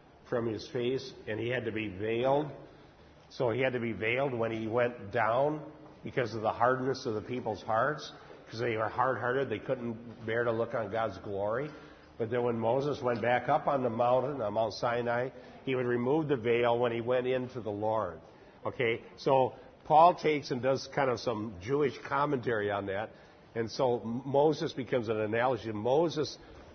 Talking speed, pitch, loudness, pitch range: 190 wpm, 120 Hz, -31 LUFS, 115-135 Hz